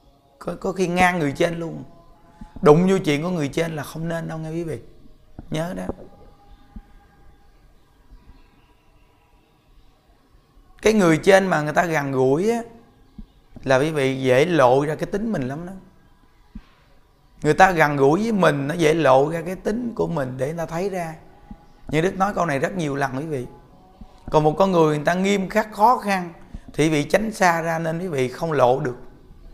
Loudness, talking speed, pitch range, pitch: -20 LUFS, 185 wpm, 140-185 Hz, 160 Hz